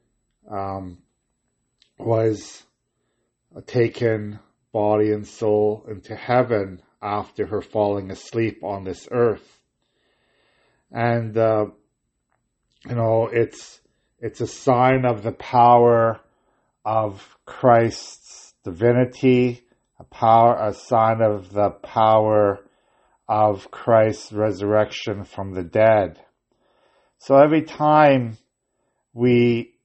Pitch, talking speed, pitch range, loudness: 110 Hz, 90 wpm, 105-120 Hz, -20 LUFS